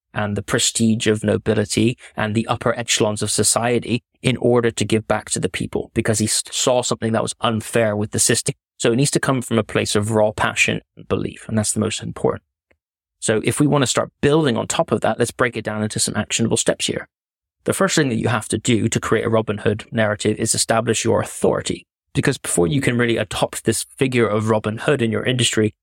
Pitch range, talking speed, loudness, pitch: 105-120 Hz, 230 wpm, -19 LUFS, 115 Hz